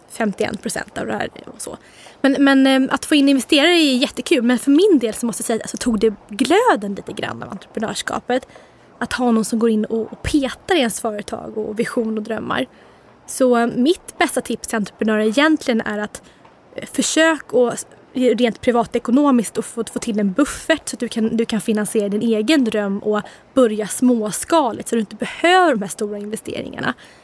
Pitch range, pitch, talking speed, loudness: 220-275 Hz, 235 Hz, 185 wpm, -18 LUFS